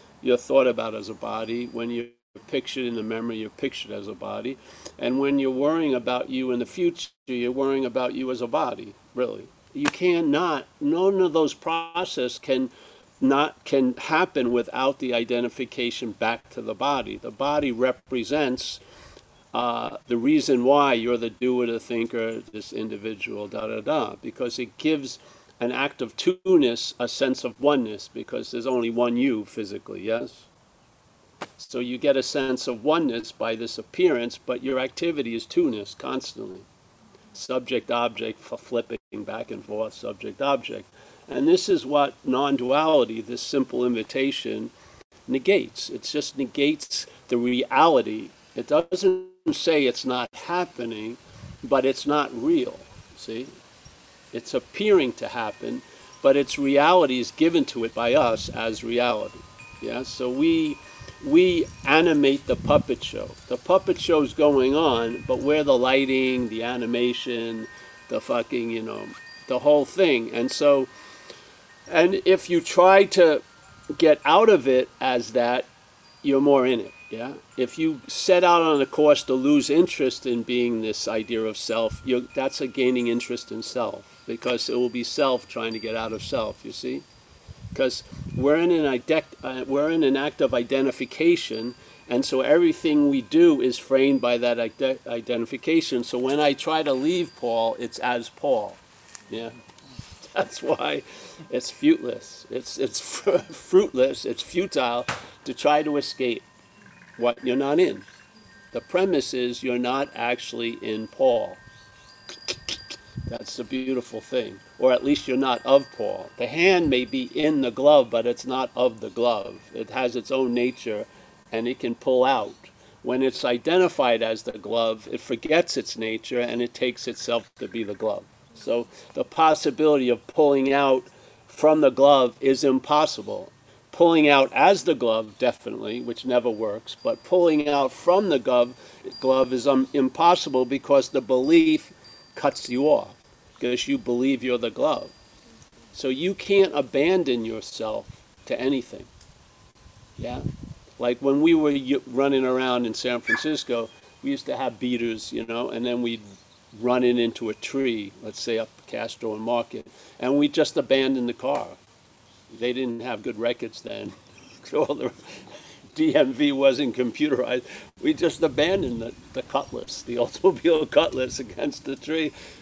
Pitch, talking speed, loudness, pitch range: 130 Hz, 155 wpm, -23 LUFS, 120-150 Hz